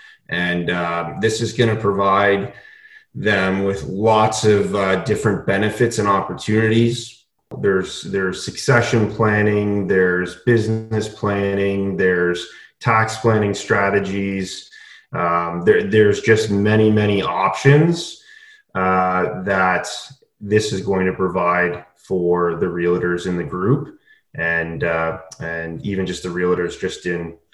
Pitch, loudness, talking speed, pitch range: 100 Hz, -18 LUFS, 120 wpm, 90-110 Hz